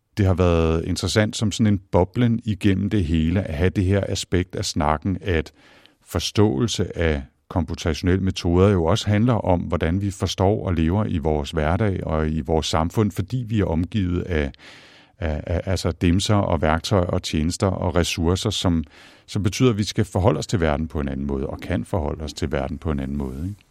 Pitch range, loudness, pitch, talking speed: 80-105 Hz, -22 LUFS, 90 Hz, 200 wpm